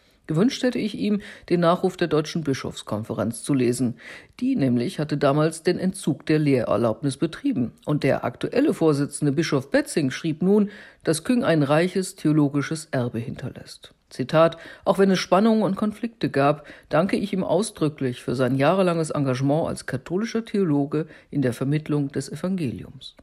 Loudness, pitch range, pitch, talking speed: -23 LUFS, 140-190 Hz, 155 Hz, 150 wpm